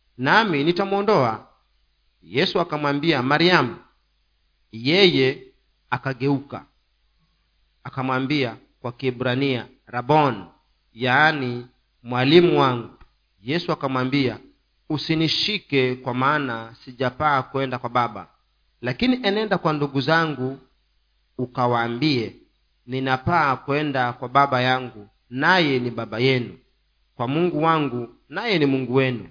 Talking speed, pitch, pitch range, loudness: 90 wpm, 130 Hz, 120-150 Hz, -21 LUFS